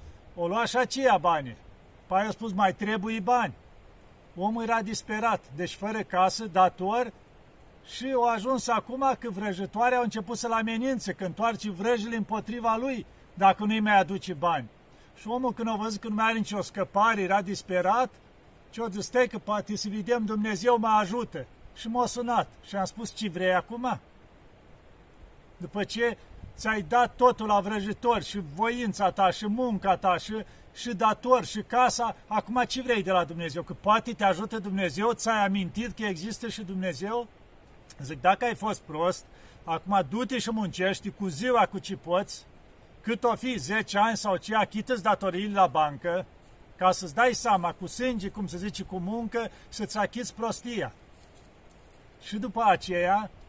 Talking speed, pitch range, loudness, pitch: 165 wpm, 190-230 Hz, -28 LUFS, 210 Hz